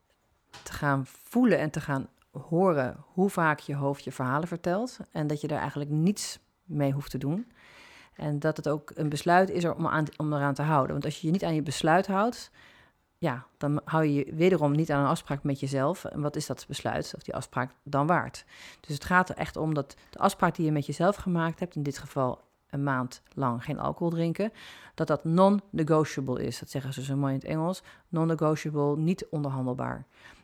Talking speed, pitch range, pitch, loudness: 210 wpm, 140-170 Hz, 150 Hz, -29 LUFS